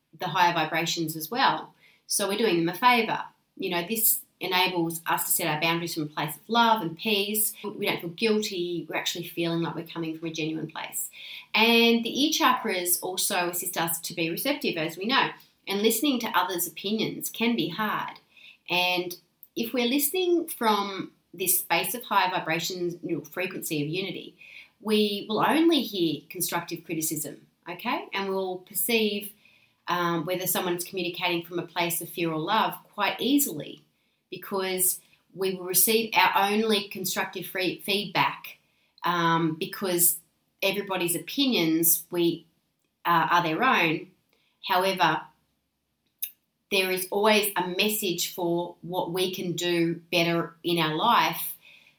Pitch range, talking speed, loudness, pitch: 170-205 Hz, 155 wpm, -26 LUFS, 180 Hz